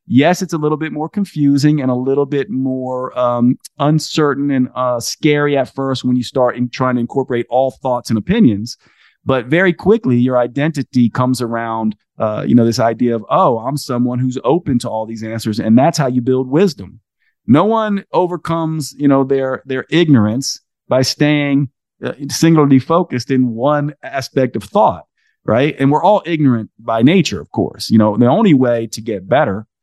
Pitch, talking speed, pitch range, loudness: 130 Hz, 185 wpm, 120-150 Hz, -15 LUFS